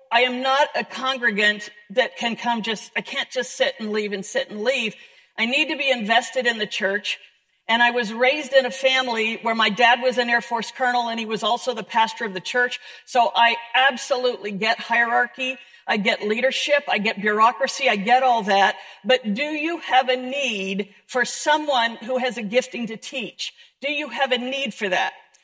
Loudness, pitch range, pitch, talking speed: -21 LUFS, 210-260 Hz, 235 Hz, 205 wpm